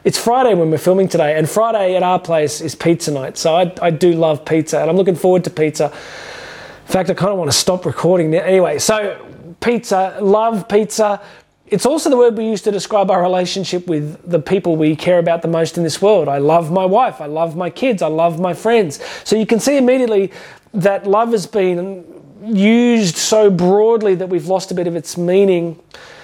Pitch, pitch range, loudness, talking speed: 185 Hz, 170-205 Hz, -15 LUFS, 215 wpm